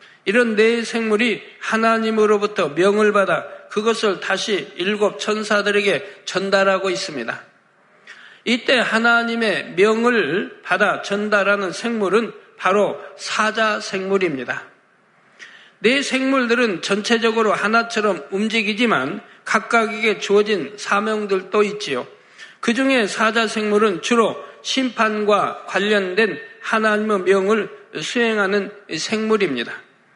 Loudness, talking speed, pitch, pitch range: -19 LUFS, 255 characters per minute, 215 Hz, 200-230 Hz